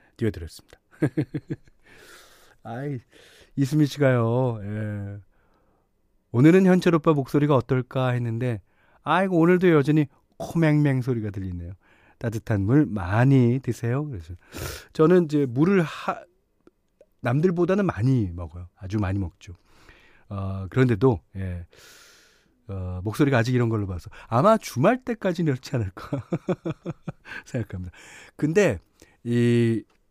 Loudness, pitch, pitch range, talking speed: -23 LUFS, 125 Hz, 105-150 Hz, 255 characters per minute